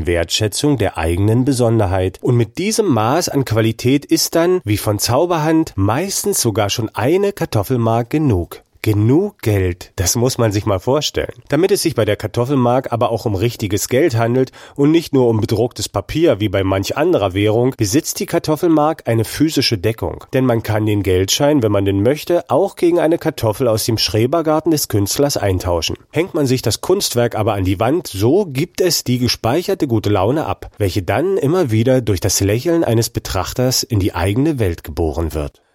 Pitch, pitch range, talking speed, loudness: 115 Hz, 105-145 Hz, 185 wpm, -16 LUFS